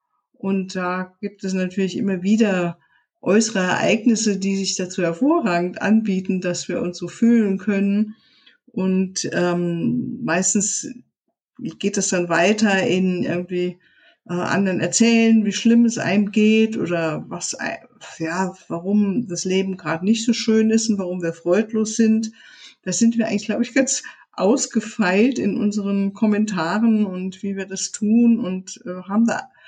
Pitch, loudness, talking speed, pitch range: 205 Hz, -20 LUFS, 150 wpm, 185-225 Hz